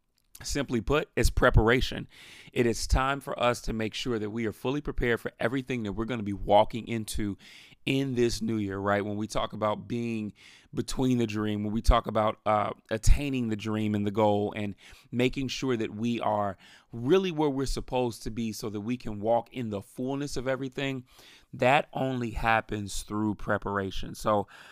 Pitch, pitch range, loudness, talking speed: 115 Hz, 105-125 Hz, -29 LUFS, 190 wpm